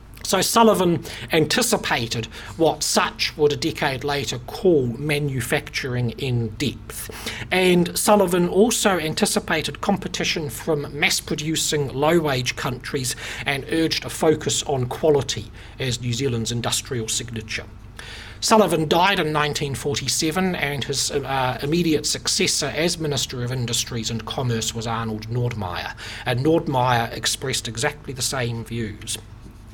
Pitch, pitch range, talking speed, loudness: 135 Hz, 115-155 Hz, 120 wpm, -22 LUFS